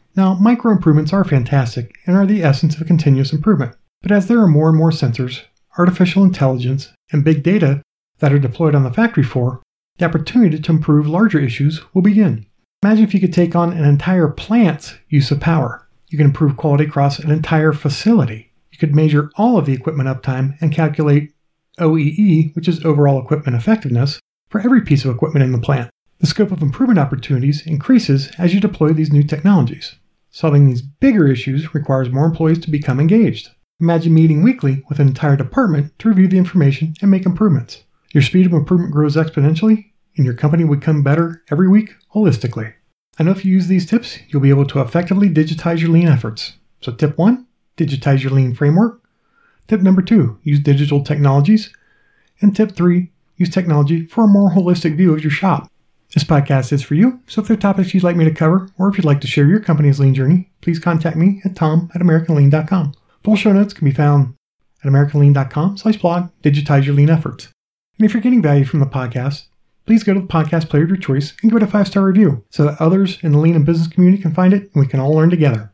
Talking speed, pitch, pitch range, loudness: 210 wpm, 160 Hz, 140-185 Hz, -15 LUFS